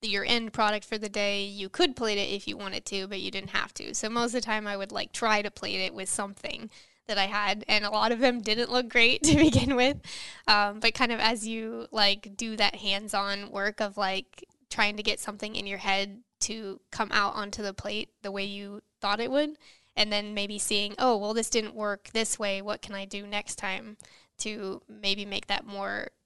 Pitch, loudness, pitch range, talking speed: 210 Hz, -28 LUFS, 200-225 Hz, 235 wpm